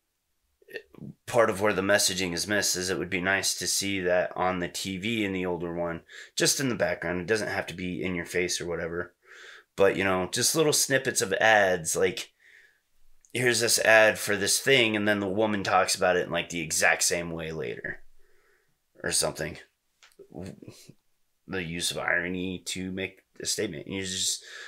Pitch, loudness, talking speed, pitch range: 95 Hz, -26 LUFS, 185 wpm, 90-105 Hz